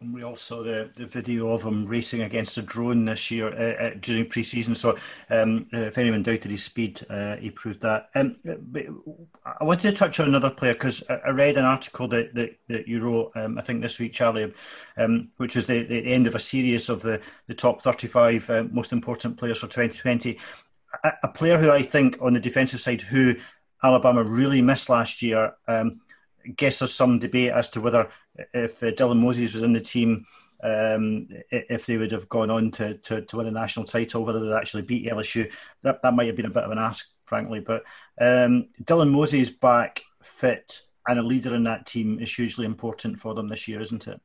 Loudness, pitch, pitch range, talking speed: -24 LUFS, 115 Hz, 115-125 Hz, 215 wpm